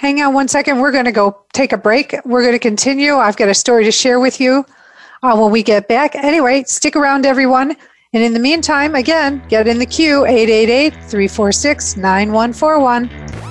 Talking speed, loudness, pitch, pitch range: 195 wpm, -12 LUFS, 255 Hz, 225-280 Hz